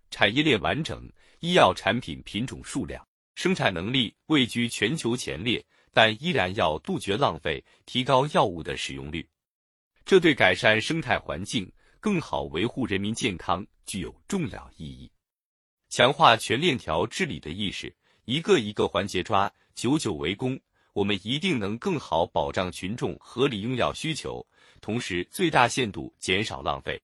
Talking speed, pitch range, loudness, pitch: 240 characters per minute, 95-130 Hz, -26 LUFS, 110 Hz